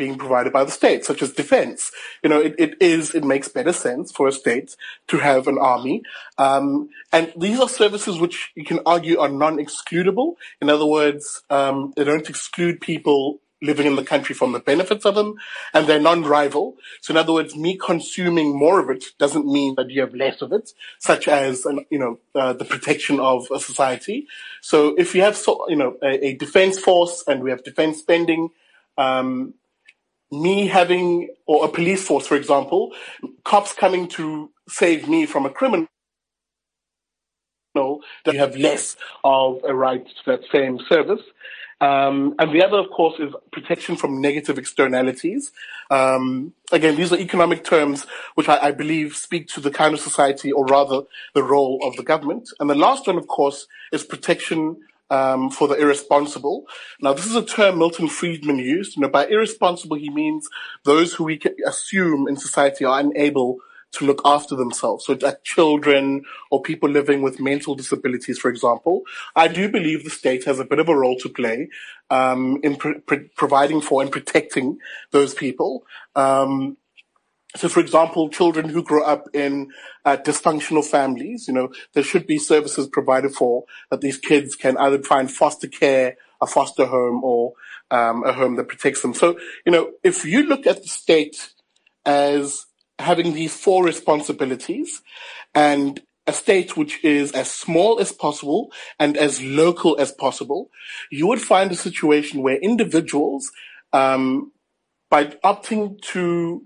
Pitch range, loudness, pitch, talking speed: 140-175 Hz, -19 LUFS, 150 Hz, 175 wpm